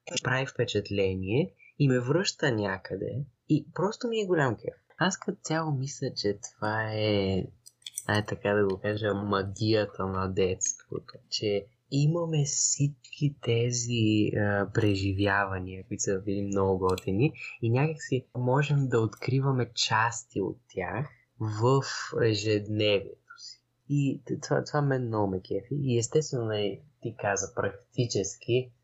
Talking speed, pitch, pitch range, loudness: 130 wpm, 120 Hz, 100-140 Hz, -29 LUFS